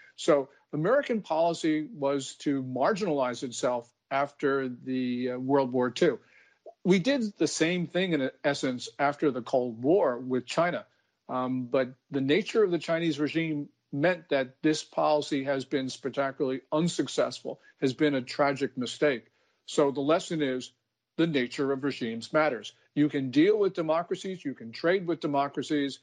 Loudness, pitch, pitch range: -29 LUFS, 140 Hz, 130-160 Hz